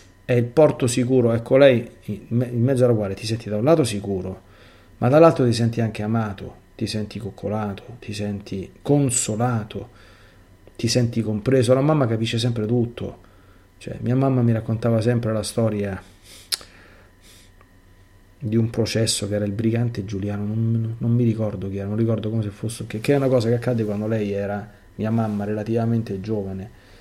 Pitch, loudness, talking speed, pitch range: 110 Hz, -22 LUFS, 175 wpm, 100-120 Hz